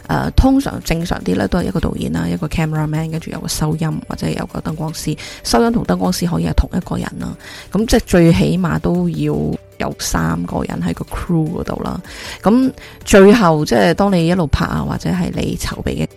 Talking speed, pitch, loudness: 355 characters per minute, 155 Hz, -16 LUFS